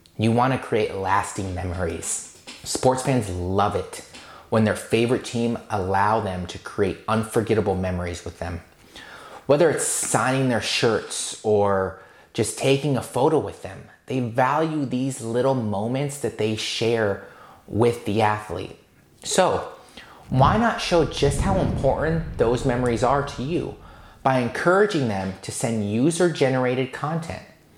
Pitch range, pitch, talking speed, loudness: 100-130 Hz, 115 Hz, 140 wpm, -23 LUFS